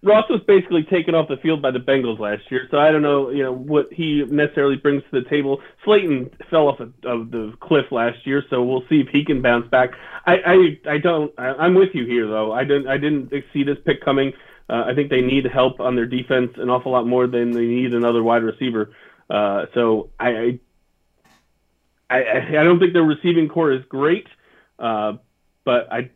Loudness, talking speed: -19 LUFS, 220 wpm